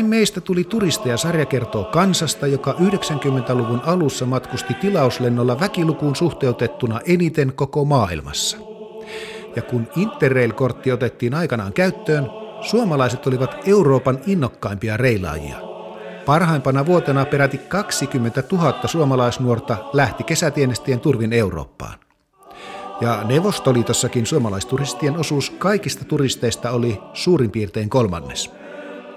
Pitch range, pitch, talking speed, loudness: 120-165 Hz, 135 Hz, 95 wpm, -19 LUFS